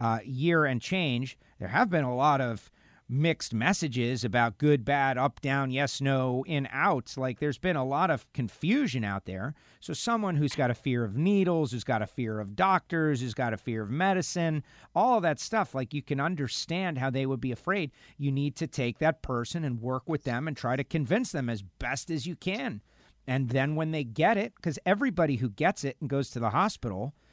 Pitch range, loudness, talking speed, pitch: 125-165 Hz, -29 LUFS, 215 wpm, 140 Hz